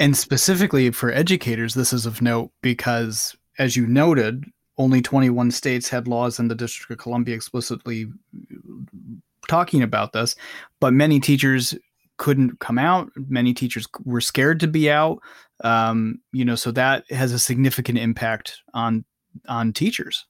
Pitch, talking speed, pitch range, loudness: 125 Hz, 150 wpm, 120-135 Hz, -21 LUFS